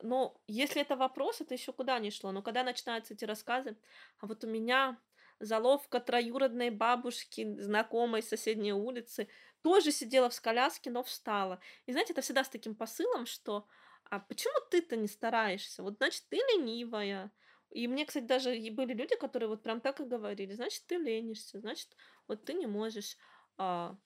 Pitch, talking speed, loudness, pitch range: 240 Hz, 170 wpm, -35 LUFS, 220-265 Hz